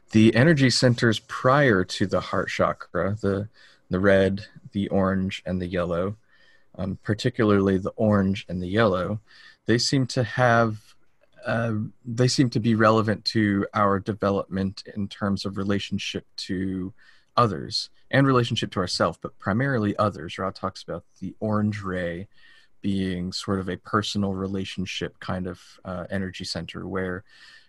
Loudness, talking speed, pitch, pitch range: -24 LUFS, 145 wpm, 100 Hz, 95-110 Hz